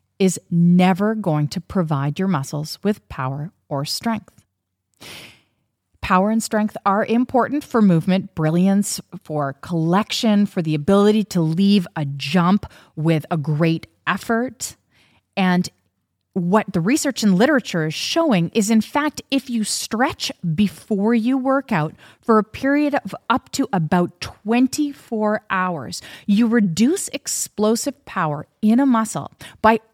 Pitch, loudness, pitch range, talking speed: 195 Hz, -20 LUFS, 165-225 Hz, 135 wpm